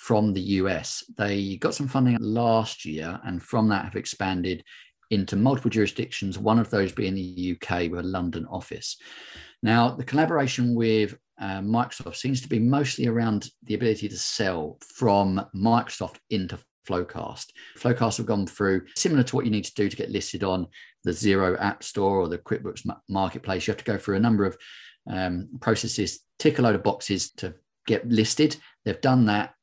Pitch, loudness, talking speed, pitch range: 105 Hz, -26 LUFS, 180 wpm, 95-115 Hz